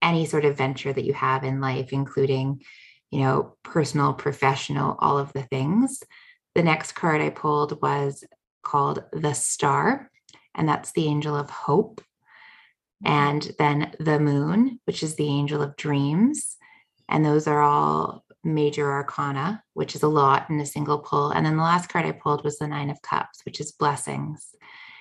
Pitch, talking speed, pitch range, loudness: 145 Hz, 175 wpm, 140-155 Hz, -24 LUFS